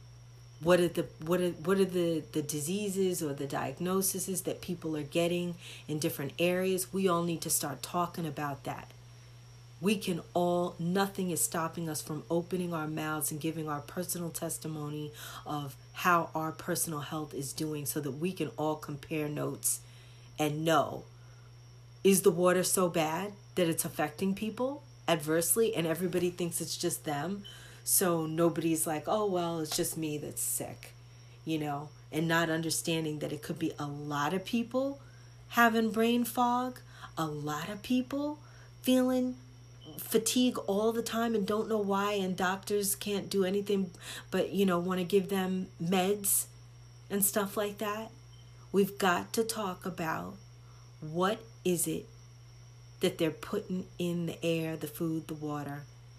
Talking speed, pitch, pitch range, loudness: 160 wpm, 165 Hz, 145-190 Hz, -32 LUFS